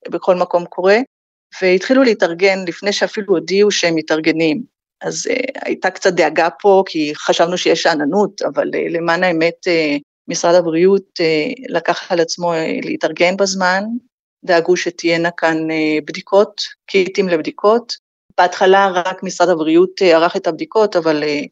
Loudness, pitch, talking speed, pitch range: -15 LUFS, 180 Hz, 140 wpm, 165-195 Hz